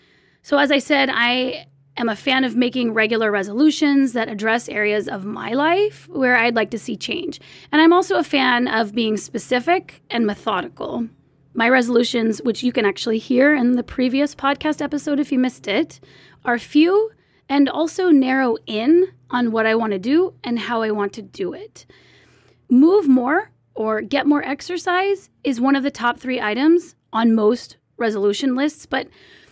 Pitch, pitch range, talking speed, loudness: 255 Hz, 225-295 Hz, 175 wpm, -19 LUFS